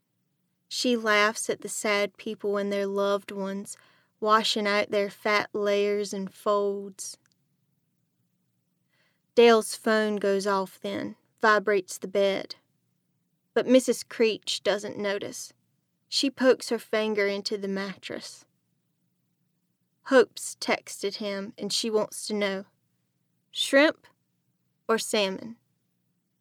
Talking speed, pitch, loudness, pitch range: 110 wpm, 205 Hz, -26 LUFS, 195-220 Hz